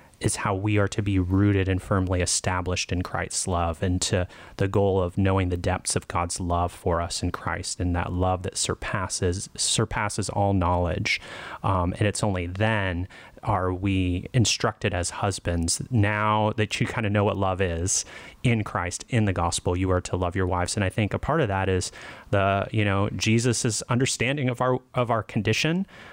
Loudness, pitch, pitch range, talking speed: -25 LUFS, 100 Hz, 90-110 Hz, 195 wpm